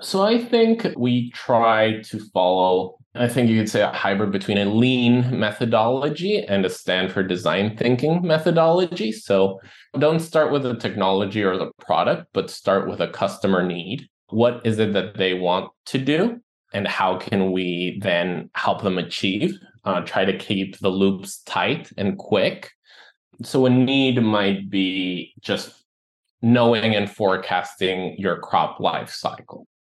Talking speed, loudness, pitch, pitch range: 155 wpm, -21 LUFS, 110 Hz, 95-130 Hz